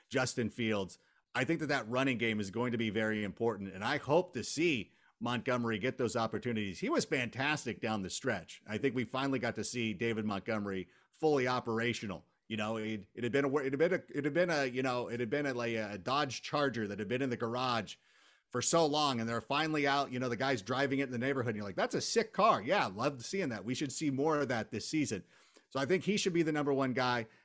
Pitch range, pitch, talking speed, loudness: 110-140 Hz, 125 Hz, 255 wpm, -34 LUFS